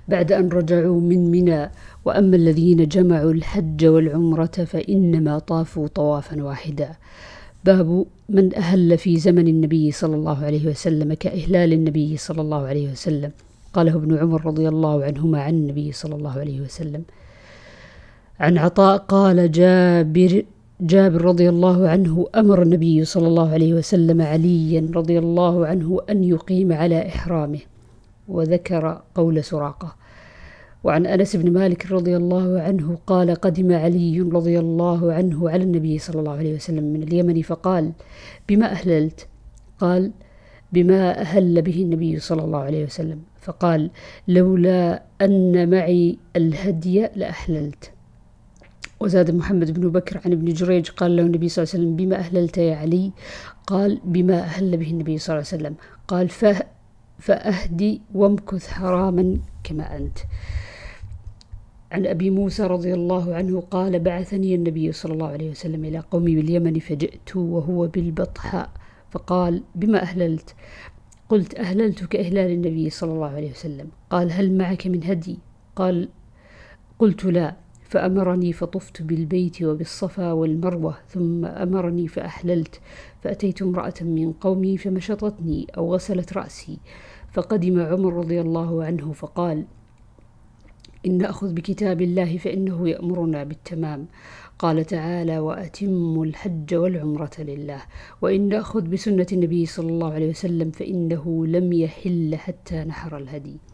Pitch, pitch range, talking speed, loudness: 170 Hz, 160-185 Hz, 130 wpm, -20 LUFS